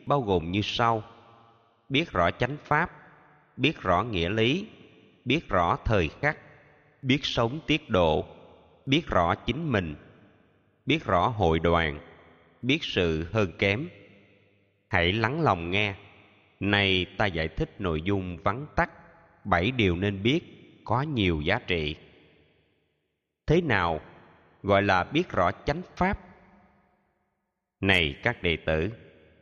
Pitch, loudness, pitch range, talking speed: 100 Hz, -26 LUFS, 85-140 Hz, 130 wpm